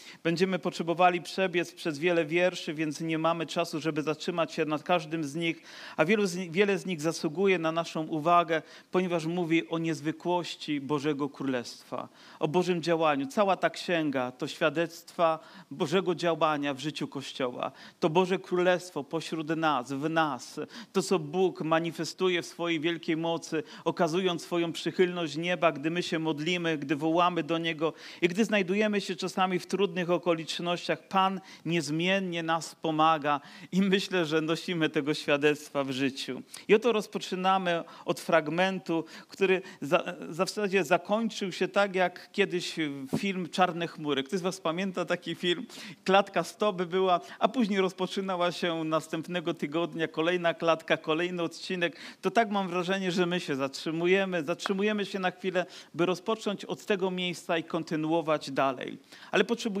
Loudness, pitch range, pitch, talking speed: -29 LUFS, 160-185 Hz, 170 Hz, 155 wpm